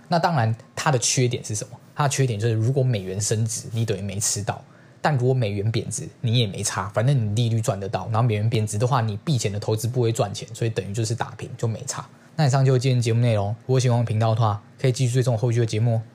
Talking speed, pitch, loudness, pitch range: 400 characters per minute, 120 Hz, -23 LUFS, 110-130 Hz